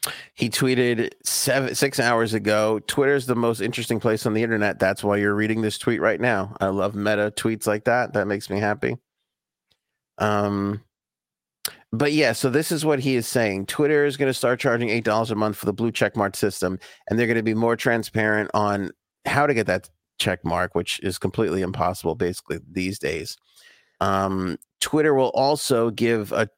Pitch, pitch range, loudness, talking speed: 110 Hz, 100-120 Hz, -23 LUFS, 190 wpm